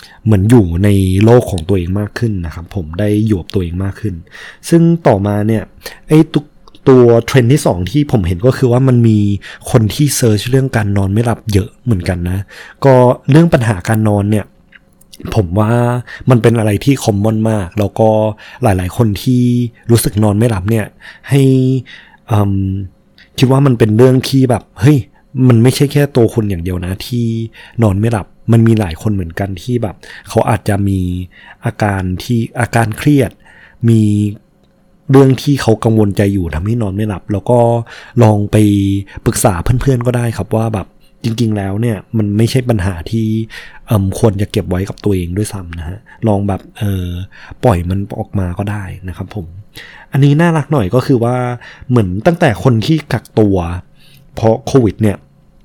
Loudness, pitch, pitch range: -13 LUFS, 110 Hz, 100-125 Hz